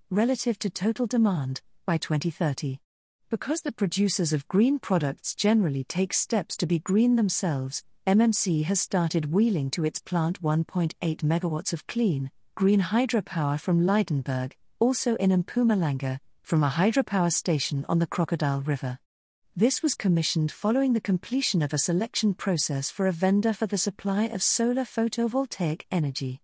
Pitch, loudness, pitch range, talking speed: 185 Hz, -26 LUFS, 155-220 Hz, 150 wpm